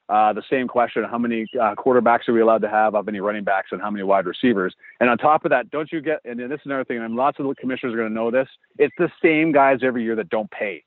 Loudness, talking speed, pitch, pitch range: -21 LUFS, 300 wpm, 120 Hz, 110-135 Hz